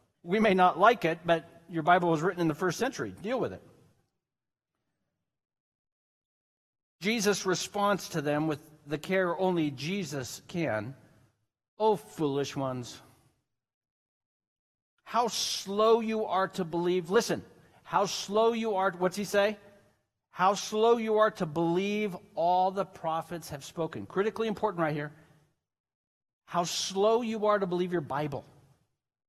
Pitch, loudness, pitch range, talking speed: 180 Hz, -29 LUFS, 150-205 Hz, 135 wpm